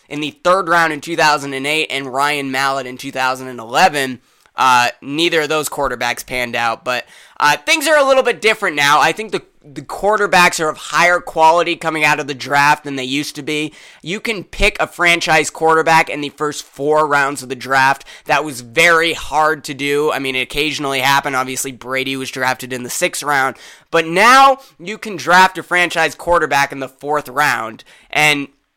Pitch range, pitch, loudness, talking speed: 135-165 Hz, 150 Hz, -15 LUFS, 190 wpm